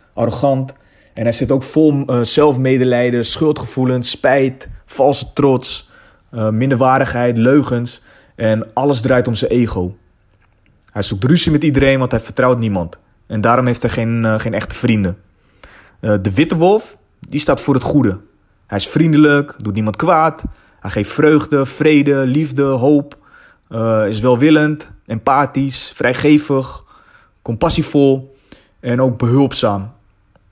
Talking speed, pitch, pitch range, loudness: 135 wpm, 125 Hz, 110-140 Hz, -15 LUFS